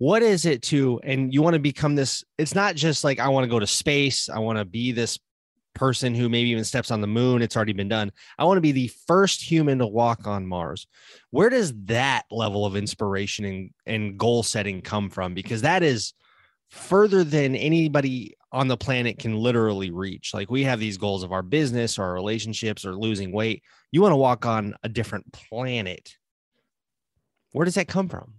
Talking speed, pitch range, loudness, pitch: 210 wpm, 105-140 Hz, -23 LUFS, 120 Hz